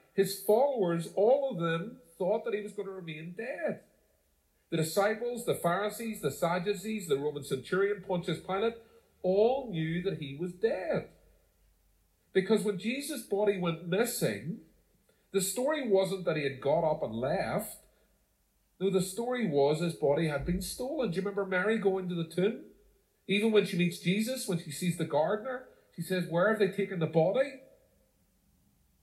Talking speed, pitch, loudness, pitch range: 165 wpm, 190 Hz, -31 LUFS, 170-215 Hz